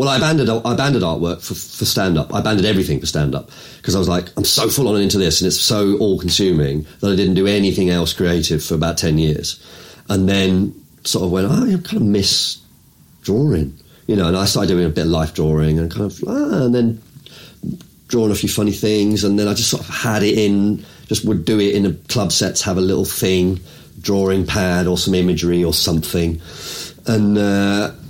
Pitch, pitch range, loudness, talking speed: 95 Hz, 85-105 Hz, -17 LUFS, 225 wpm